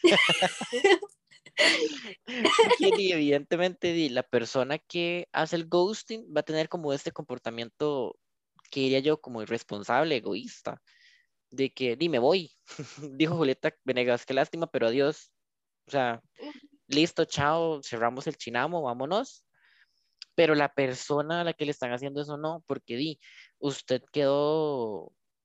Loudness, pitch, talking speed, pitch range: -28 LUFS, 155 Hz, 125 wpm, 135-175 Hz